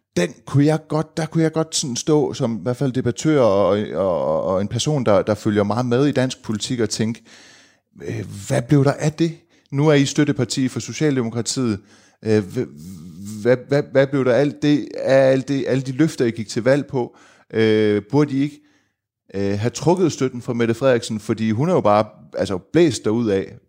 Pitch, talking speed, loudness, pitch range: 130 Hz, 210 wpm, -20 LUFS, 110-145 Hz